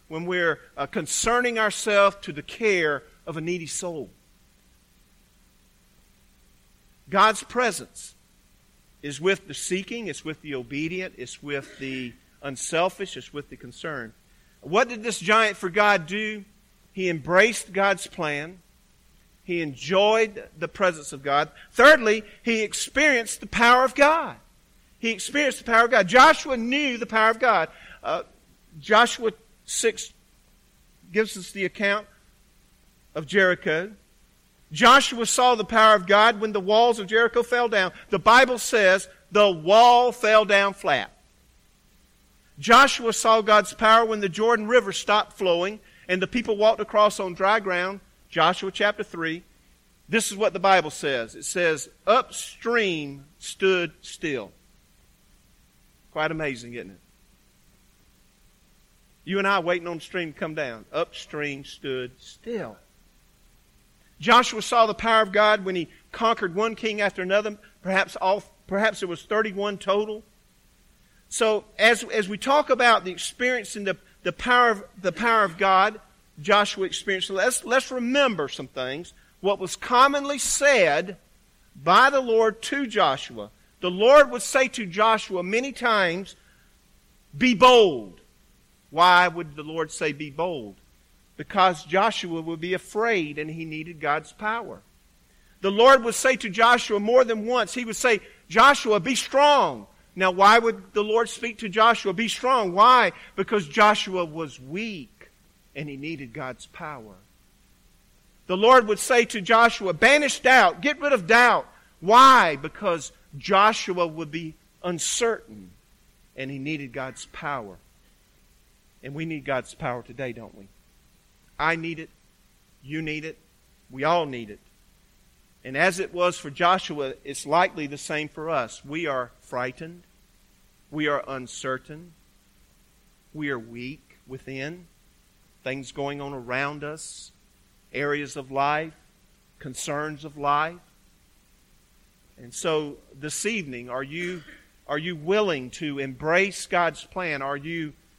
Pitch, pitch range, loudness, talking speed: 190 Hz, 155-225 Hz, -22 LUFS, 140 wpm